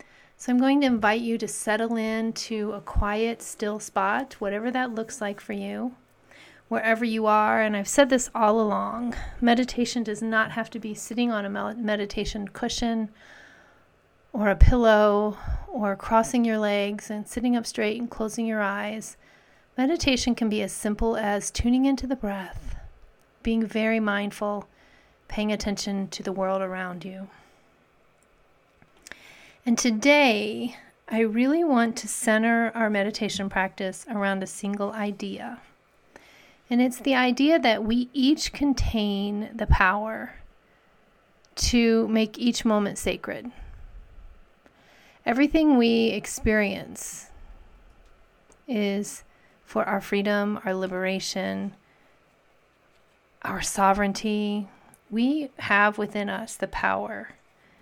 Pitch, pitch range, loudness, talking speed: 220 Hz, 205-235 Hz, -25 LUFS, 125 wpm